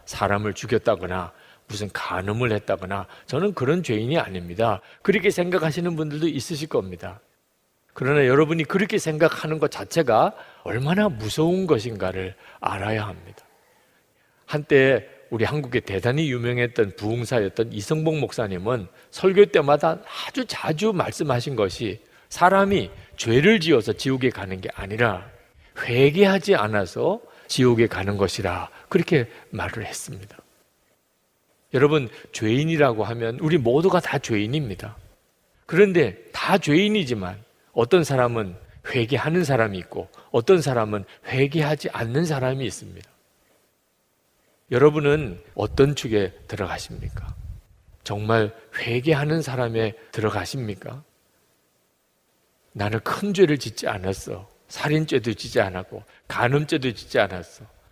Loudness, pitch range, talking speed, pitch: -23 LUFS, 100-155 Hz, 290 characters per minute, 120 Hz